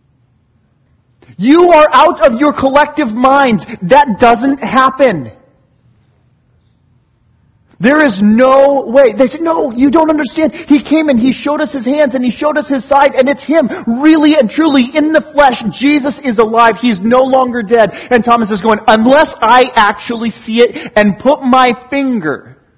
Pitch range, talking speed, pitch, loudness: 230-290 Hz, 165 wpm, 260 Hz, -10 LUFS